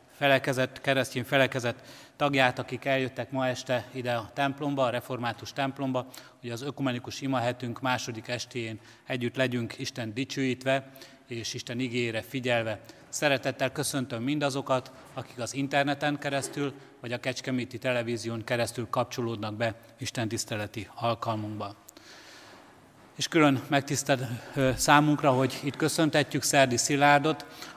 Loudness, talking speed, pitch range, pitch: -29 LUFS, 115 wpm, 120-140 Hz, 130 Hz